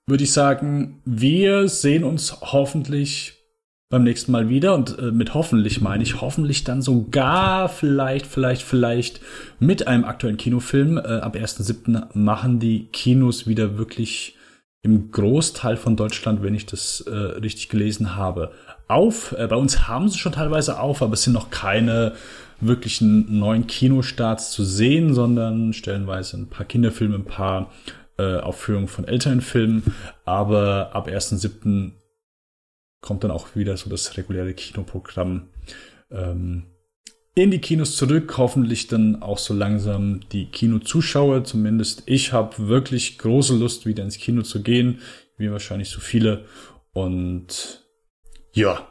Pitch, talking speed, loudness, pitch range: 115 Hz, 140 wpm, -21 LUFS, 105-130 Hz